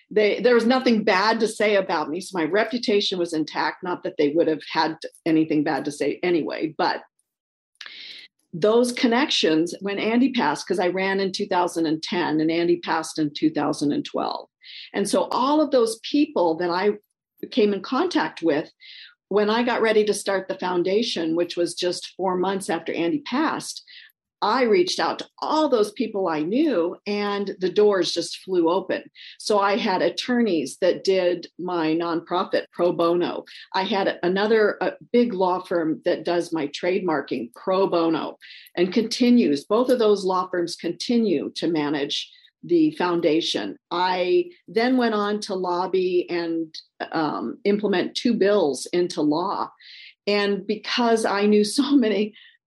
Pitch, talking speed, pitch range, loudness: 195 Hz, 155 wpm, 175-225 Hz, -23 LUFS